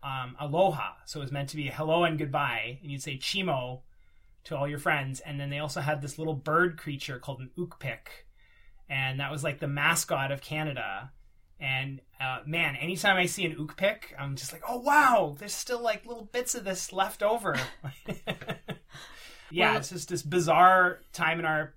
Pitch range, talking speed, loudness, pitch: 140-180 Hz, 195 wpm, -29 LUFS, 155 Hz